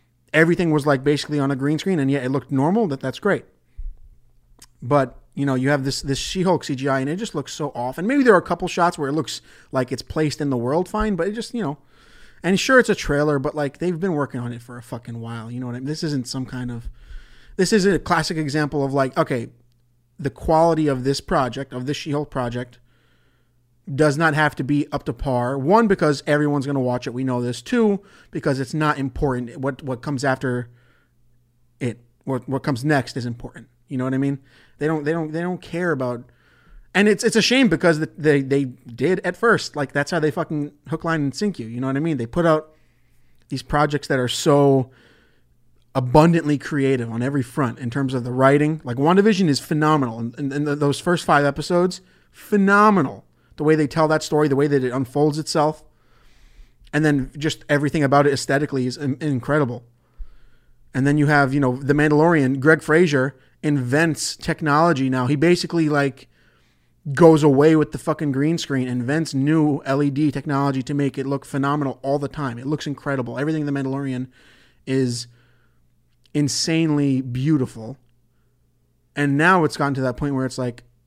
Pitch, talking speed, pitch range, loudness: 140 Hz, 205 wpm, 130-155 Hz, -20 LUFS